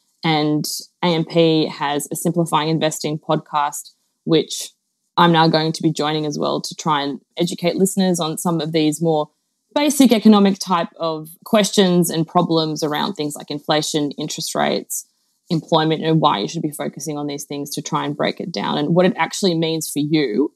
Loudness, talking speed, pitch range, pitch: -19 LUFS, 180 wpm, 150-175 Hz, 160 Hz